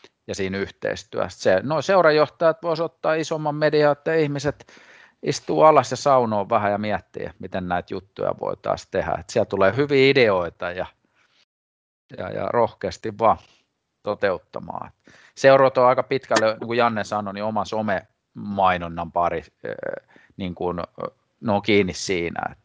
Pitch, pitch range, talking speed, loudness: 110 Hz, 95-145 Hz, 135 wpm, -22 LUFS